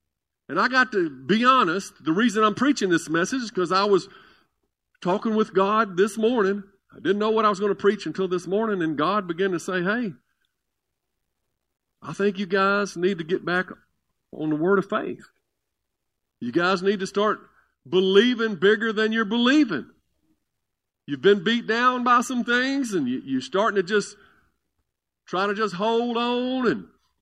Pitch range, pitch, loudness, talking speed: 190-225 Hz, 205 Hz, -23 LUFS, 180 wpm